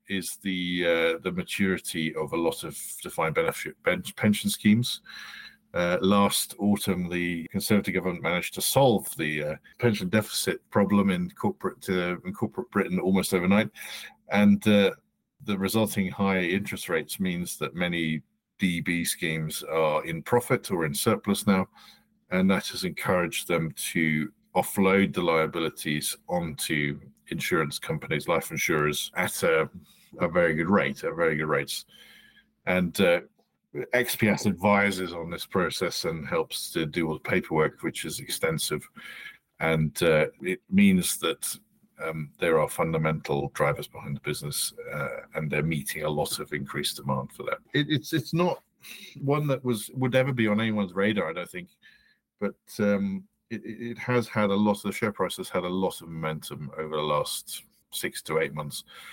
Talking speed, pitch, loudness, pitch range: 160 wpm, 95 Hz, -27 LUFS, 80-105 Hz